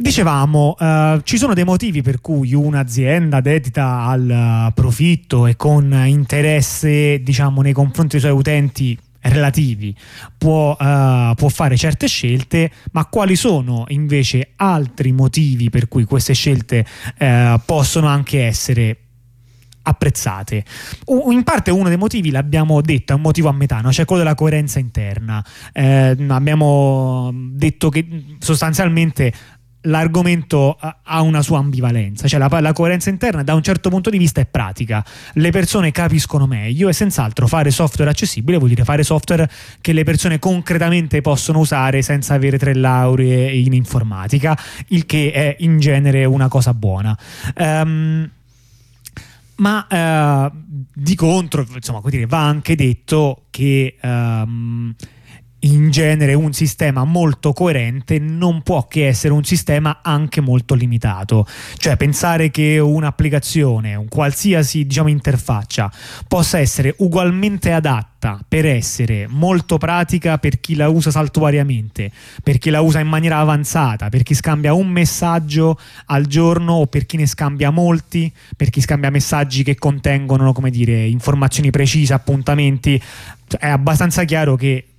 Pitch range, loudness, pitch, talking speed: 125-155 Hz, -15 LUFS, 145 Hz, 140 wpm